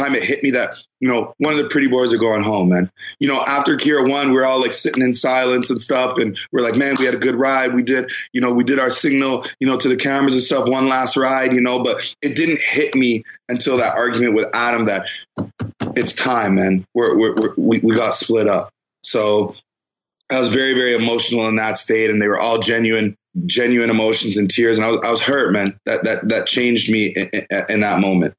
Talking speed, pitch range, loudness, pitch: 240 wpm, 110-130 Hz, -16 LUFS, 125 Hz